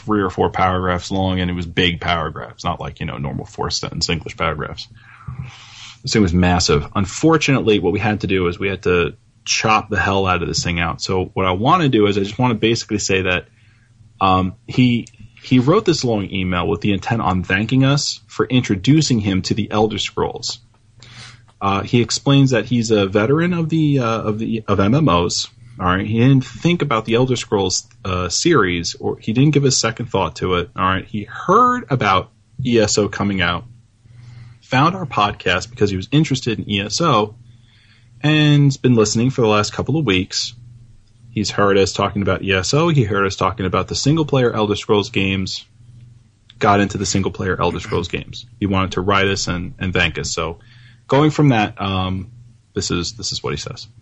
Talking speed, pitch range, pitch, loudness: 200 wpm, 95-120 Hz, 110 Hz, -18 LUFS